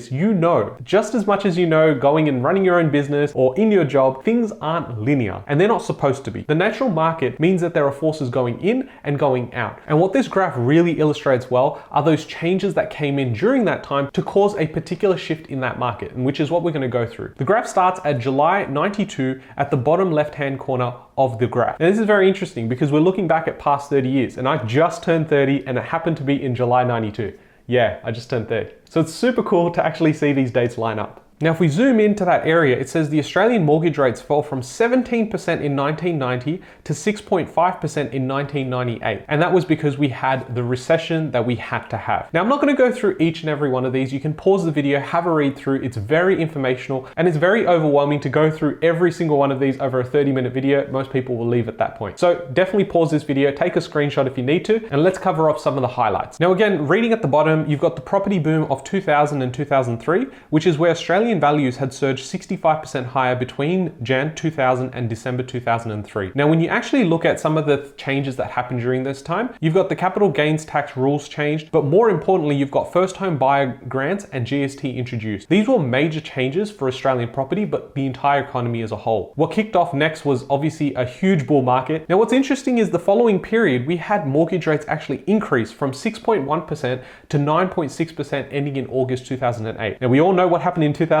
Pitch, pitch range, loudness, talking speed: 150 Hz, 130-175 Hz, -19 LUFS, 230 wpm